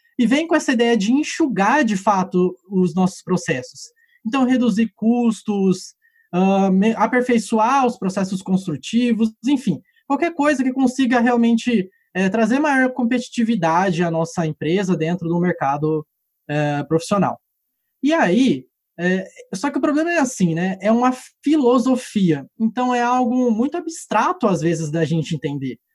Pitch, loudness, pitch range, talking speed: 225 Hz, -19 LUFS, 180-260 Hz, 140 wpm